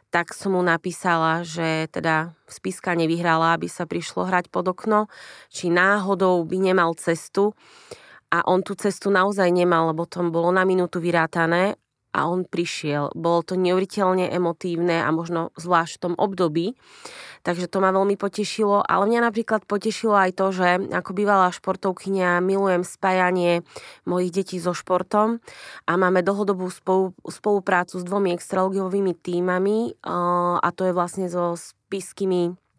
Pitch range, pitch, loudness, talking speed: 175-195 Hz, 180 Hz, -22 LUFS, 145 wpm